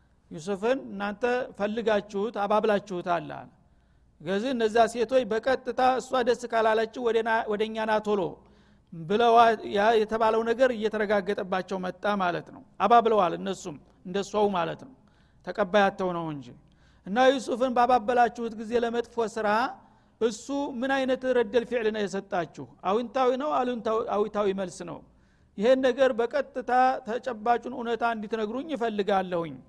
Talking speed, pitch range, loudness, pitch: 110 wpm, 200-245 Hz, -26 LUFS, 220 Hz